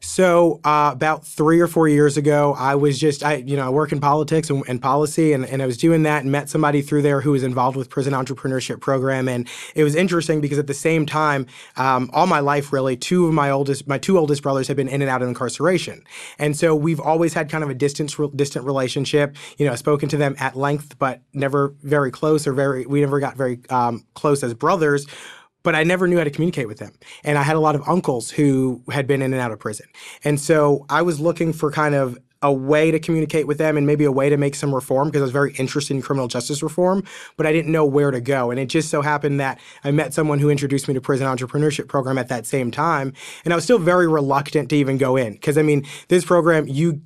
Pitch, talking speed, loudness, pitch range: 145 Hz, 255 wpm, -19 LUFS, 135-155 Hz